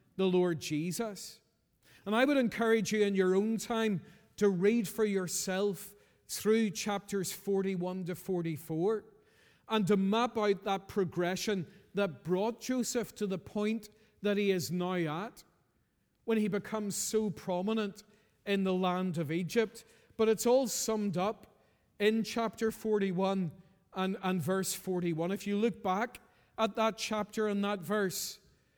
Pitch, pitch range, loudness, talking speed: 205 Hz, 185-220 Hz, -33 LUFS, 145 wpm